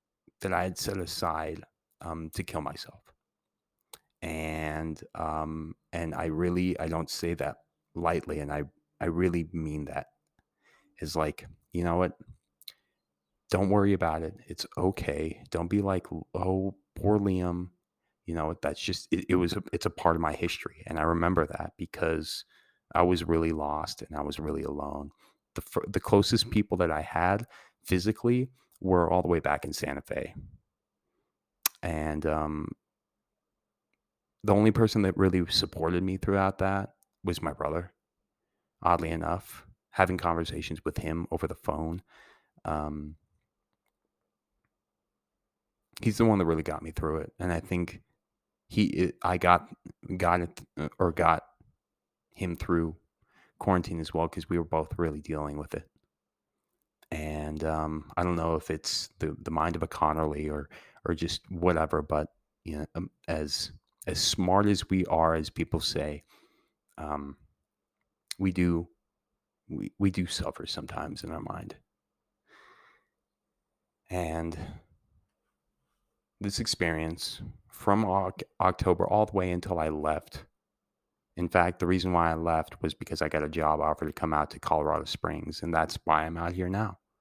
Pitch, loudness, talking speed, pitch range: 85 Hz, -30 LUFS, 150 wpm, 80-90 Hz